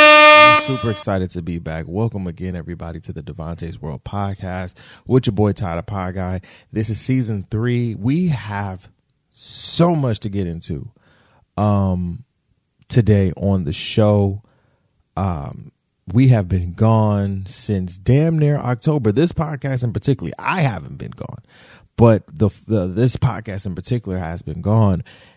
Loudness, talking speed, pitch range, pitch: -18 LUFS, 145 wpm, 90-125 Hz, 105 Hz